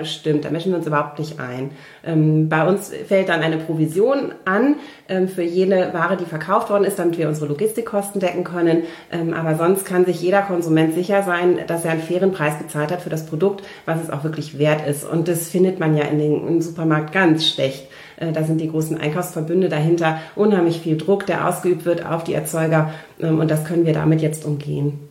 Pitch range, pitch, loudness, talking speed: 155-180 Hz, 165 Hz, -20 LUFS, 200 wpm